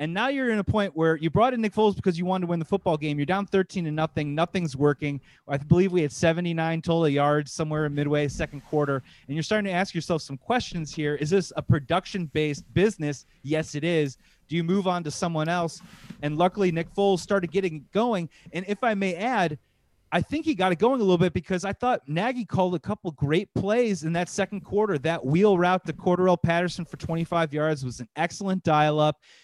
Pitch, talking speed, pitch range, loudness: 170 Hz, 225 wpm, 155-195 Hz, -25 LUFS